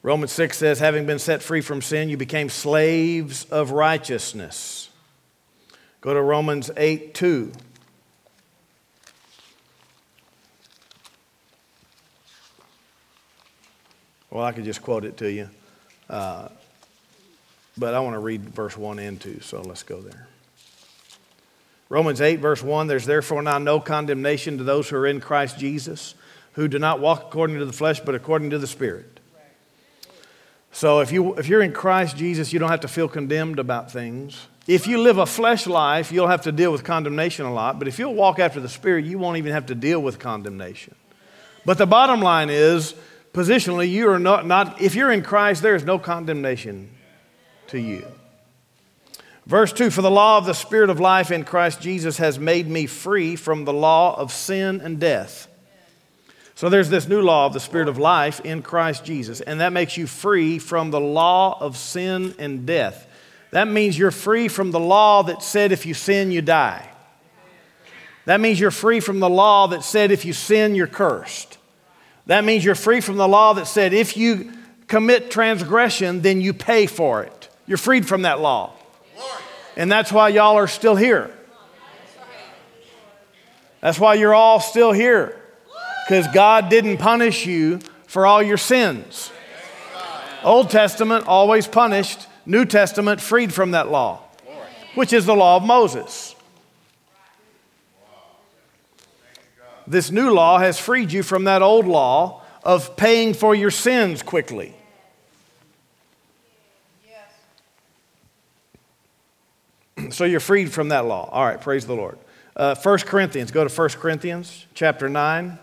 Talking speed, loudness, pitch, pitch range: 160 wpm, -18 LUFS, 175 Hz, 150-205 Hz